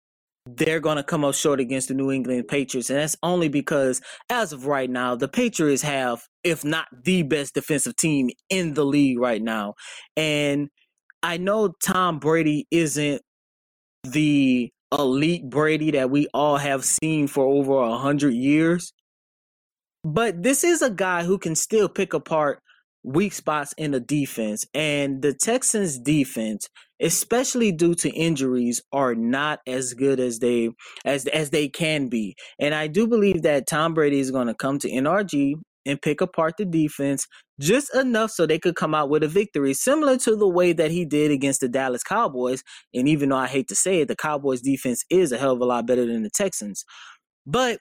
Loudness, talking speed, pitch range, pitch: -22 LUFS, 185 wpm, 135-170 Hz, 150 Hz